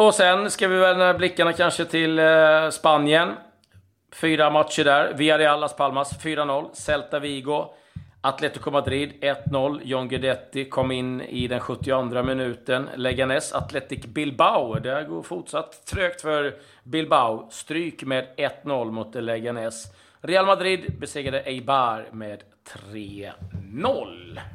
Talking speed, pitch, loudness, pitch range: 120 wpm, 140 Hz, -23 LUFS, 125-155 Hz